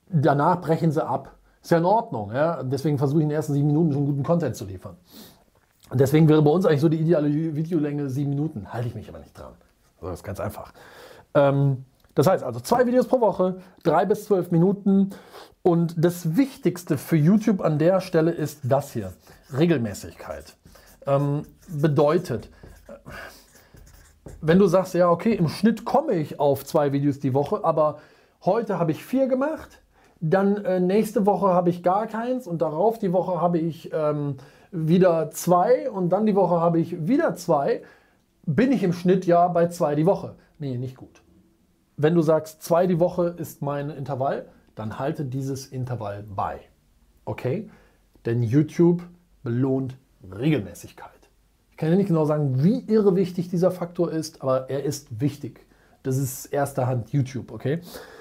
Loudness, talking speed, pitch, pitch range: -23 LUFS, 170 wpm, 160 Hz, 140-180 Hz